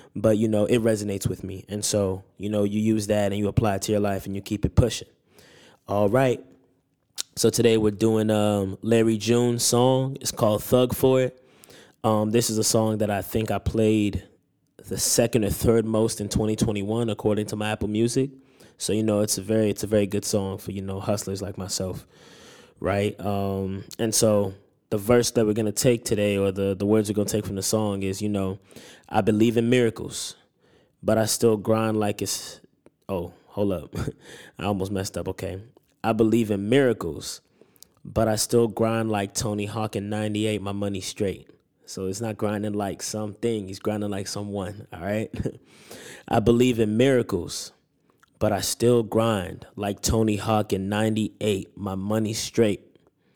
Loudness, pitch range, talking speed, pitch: -24 LUFS, 100-115 Hz, 185 wpm, 105 Hz